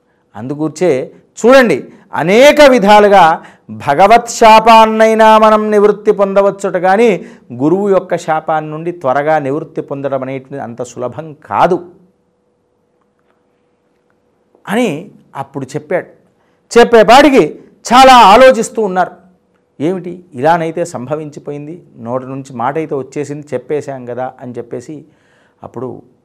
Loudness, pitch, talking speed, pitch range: -9 LUFS, 165 Hz, 90 wpm, 140-210 Hz